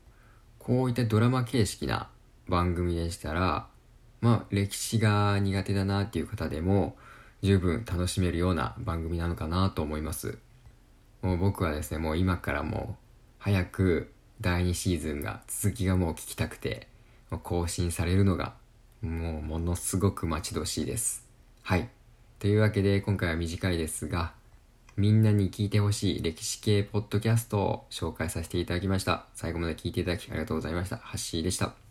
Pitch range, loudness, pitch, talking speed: 85-105 Hz, -29 LUFS, 95 Hz, 345 characters per minute